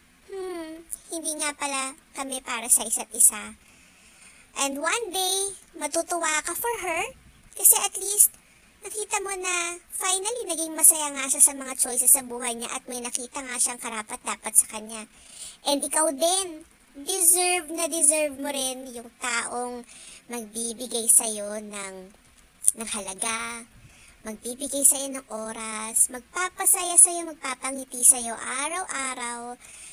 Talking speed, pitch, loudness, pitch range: 130 wpm, 270 Hz, -22 LUFS, 240-335 Hz